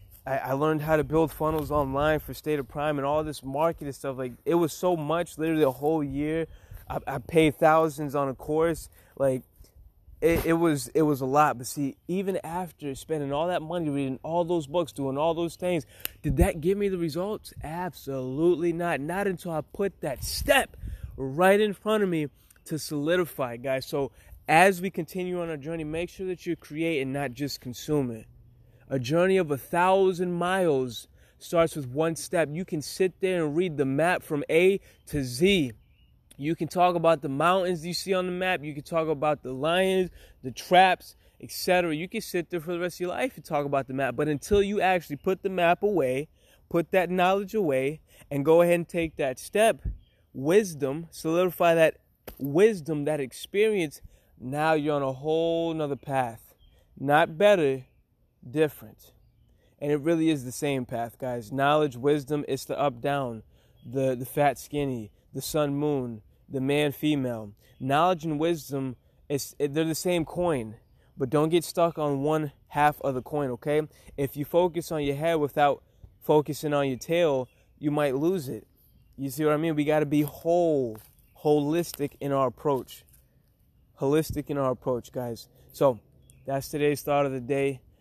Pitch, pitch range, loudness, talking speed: 150 Hz, 135-170 Hz, -27 LUFS, 185 wpm